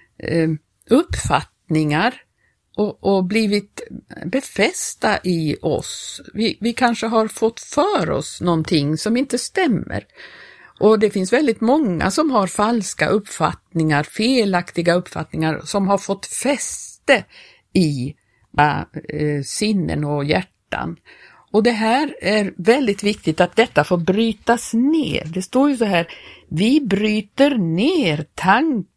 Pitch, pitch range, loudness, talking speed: 205 Hz, 170-235 Hz, -19 LUFS, 125 wpm